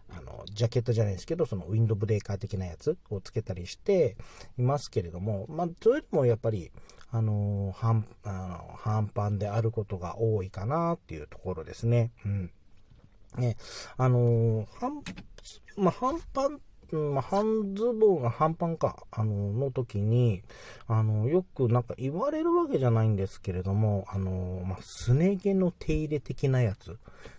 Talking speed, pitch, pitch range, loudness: 335 characters per minute, 115 Hz, 100-145 Hz, -29 LUFS